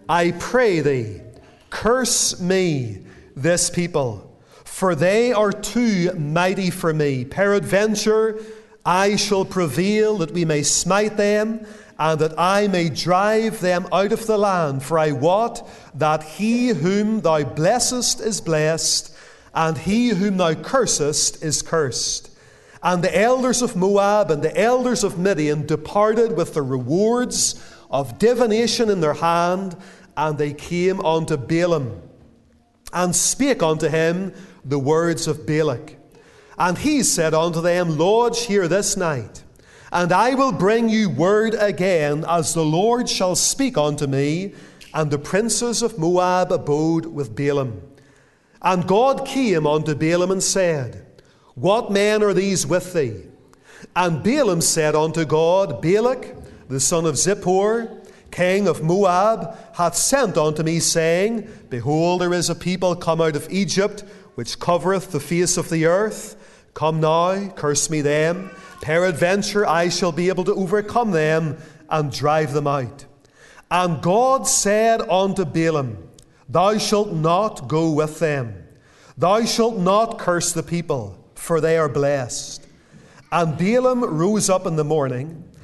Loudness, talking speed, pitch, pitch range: -19 LUFS, 145 wpm, 175 Hz, 155-205 Hz